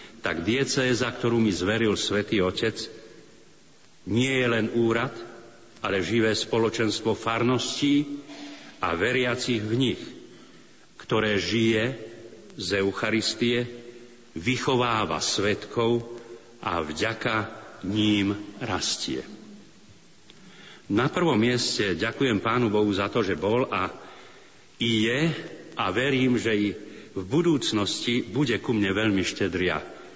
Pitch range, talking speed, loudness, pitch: 105-120 Hz, 105 wpm, -25 LUFS, 115 Hz